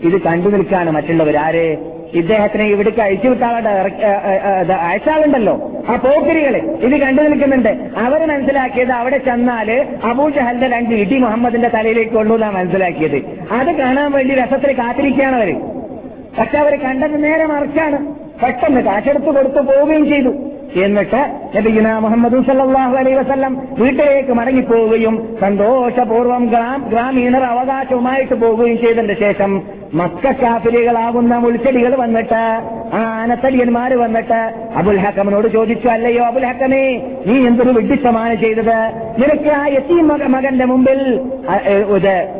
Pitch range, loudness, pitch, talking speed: 220-270 Hz, -14 LUFS, 240 Hz, 110 wpm